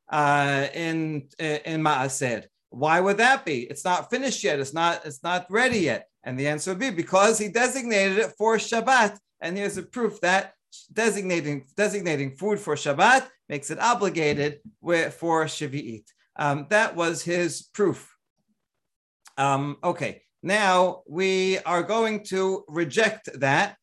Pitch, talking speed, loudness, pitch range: 175 Hz, 145 wpm, -24 LUFS, 150-210 Hz